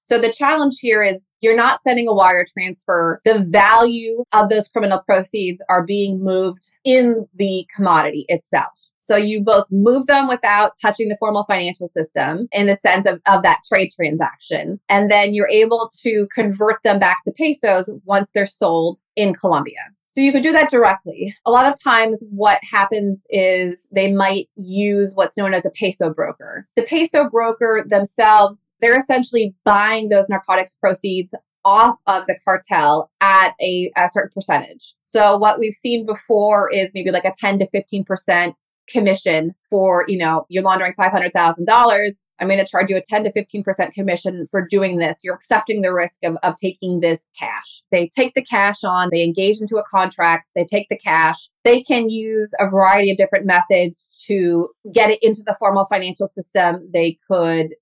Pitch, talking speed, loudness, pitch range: 200 Hz, 180 wpm, -16 LUFS, 185-215 Hz